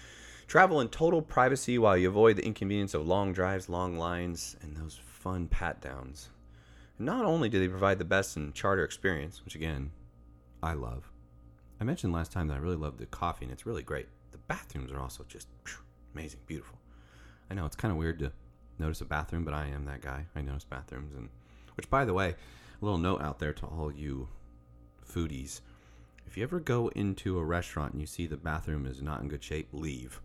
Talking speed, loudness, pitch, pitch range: 205 wpm, -32 LUFS, 75 Hz, 60-90 Hz